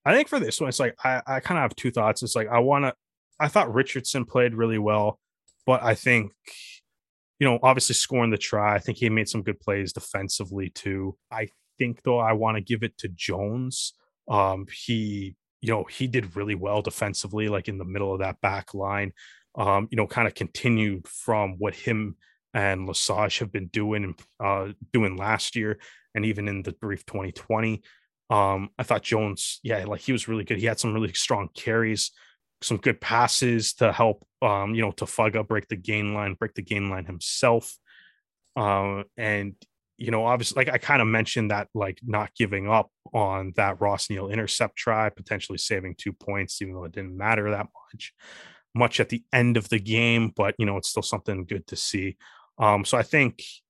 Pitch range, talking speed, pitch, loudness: 100-115 Hz, 205 wpm, 105 Hz, -25 LUFS